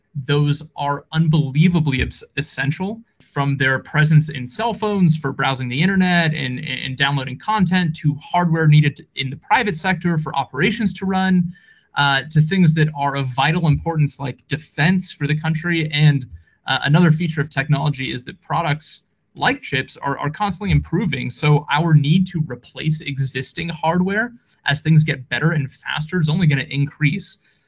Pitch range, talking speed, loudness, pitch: 140-175 Hz, 165 wpm, -19 LUFS, 155 Hz